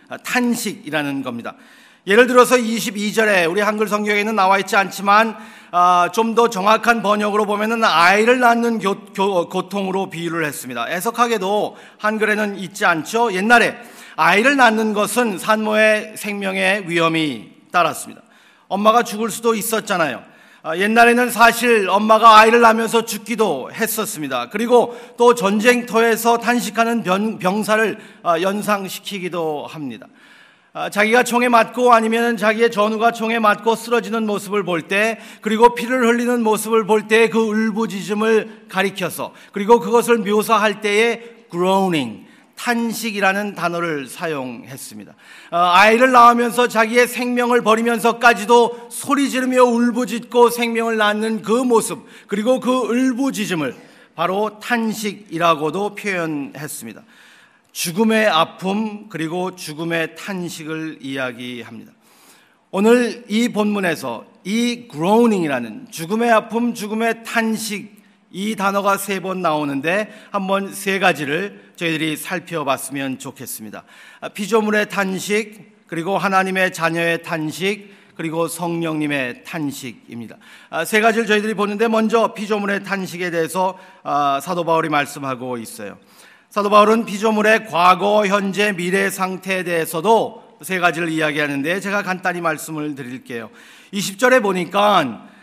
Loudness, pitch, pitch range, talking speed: -17 LUFS, 210 Hz, 180-230 Hz, 310 characters per minute